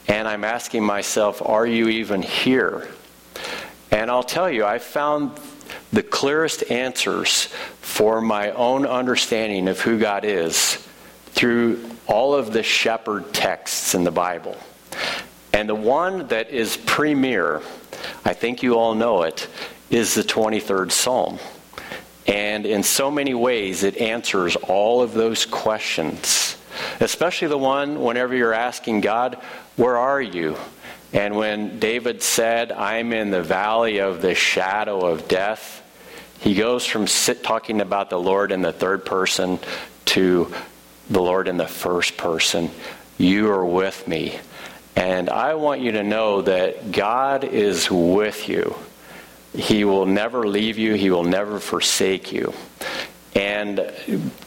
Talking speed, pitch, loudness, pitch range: 140 wpm, 110 Hz, -20 LUFS, 100-120 Hz